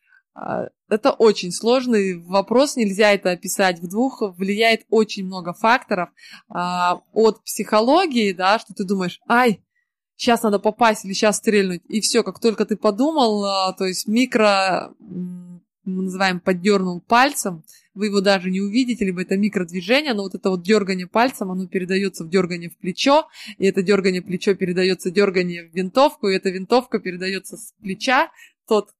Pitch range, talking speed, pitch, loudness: 185-225 Hz, 155 wpm, 200 Hz, -20 LUFS